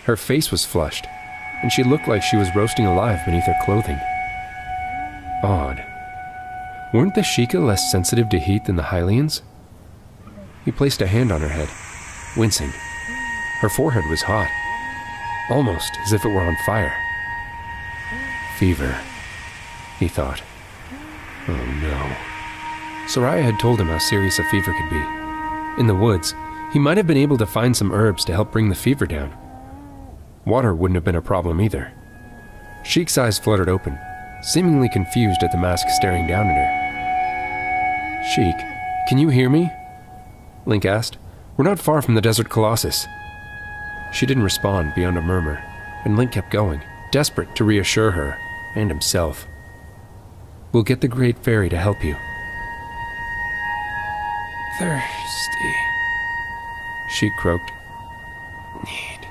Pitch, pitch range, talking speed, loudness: 105 Hz, 95-130 Hz, 140 wpm, -20 LUFS